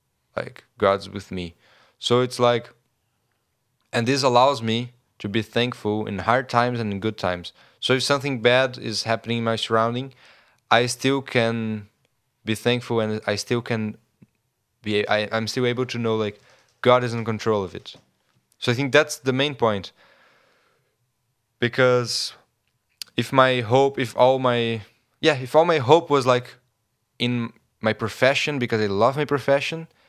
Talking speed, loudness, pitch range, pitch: 165 wpm, -22 LUFS, 110-125 Hz, 120 Hz